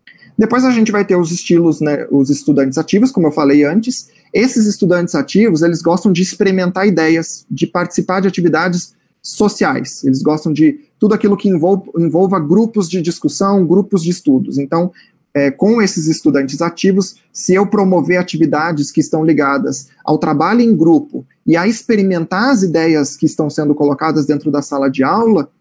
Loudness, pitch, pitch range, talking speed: -13 LUFS, 180 Hz, 155-205 Hz, 170 wpm